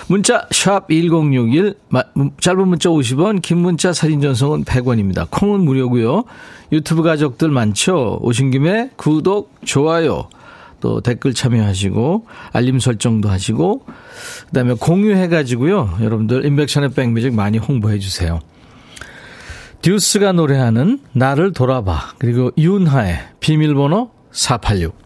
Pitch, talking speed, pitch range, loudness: 140 Hz, 265 characters per minute, 120-175 Hz, -15 LUFS